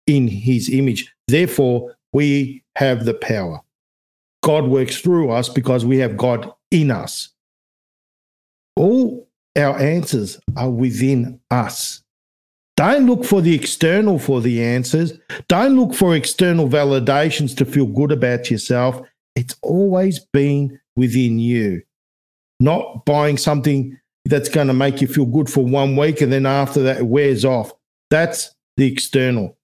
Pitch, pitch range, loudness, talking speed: 135 Hz, 125-150 Hz, -17 LUFS, 140 wpm